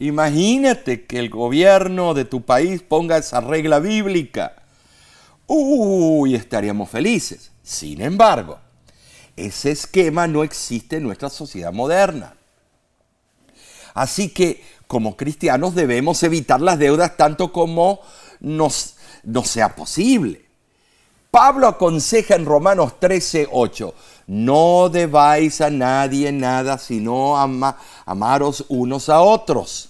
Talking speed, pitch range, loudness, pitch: 110 wpm, 130-180 Hz, -17 LUFS, 150 Hz